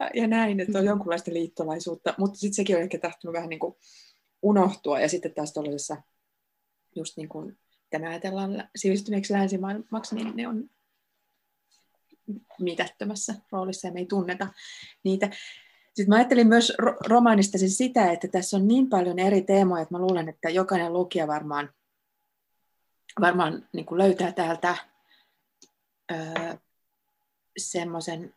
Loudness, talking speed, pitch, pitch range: -26 LUFS, 135 wpm, 190 Hz, 170-210 Hz